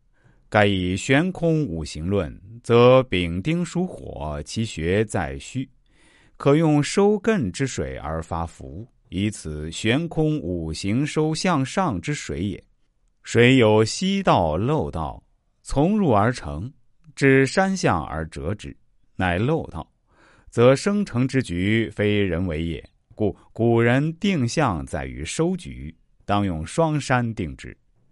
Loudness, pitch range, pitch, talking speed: -22 LUFS, 90-145 Hz, 115 Hz, 170 characters per minute